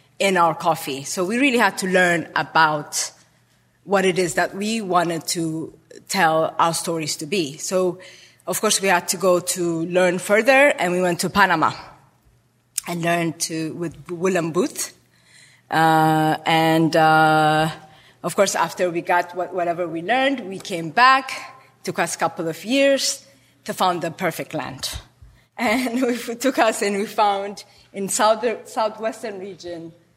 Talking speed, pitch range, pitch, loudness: 160 wpm, 165-200 Hz, 175 Hz, -20 LUFS